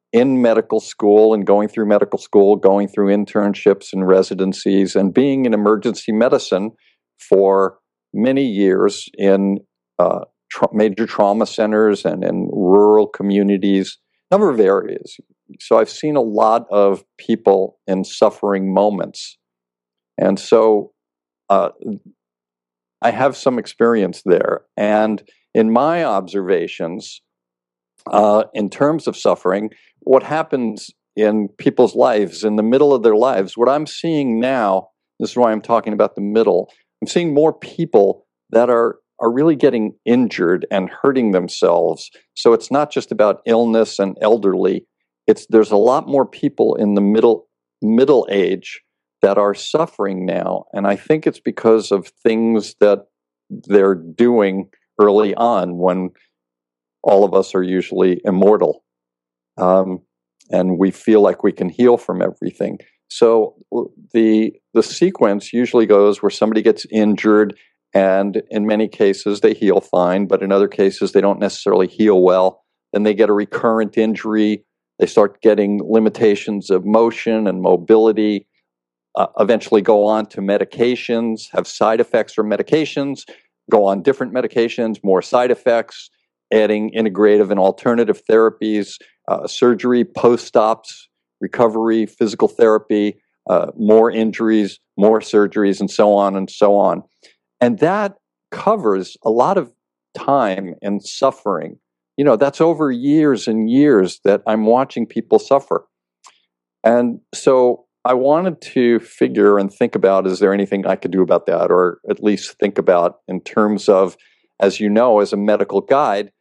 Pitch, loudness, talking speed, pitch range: 105 Hz, -16 LUFS, 150 wpm, 95-115 Hz